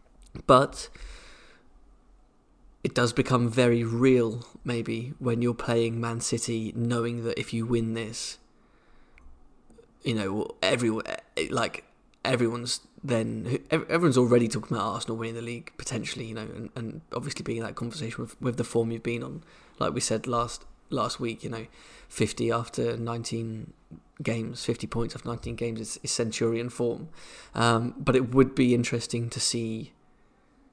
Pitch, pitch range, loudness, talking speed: 115 Hz, 115-120 Hz, -28 LUFS, 150 wpm